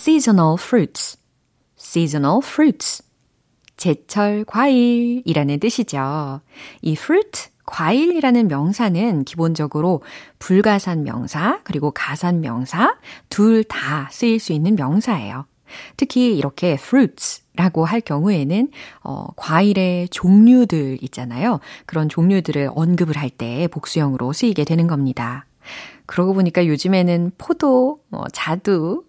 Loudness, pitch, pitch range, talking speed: -18 LUFS, 180 Hz, 150-225 Hz, 305 characters per minute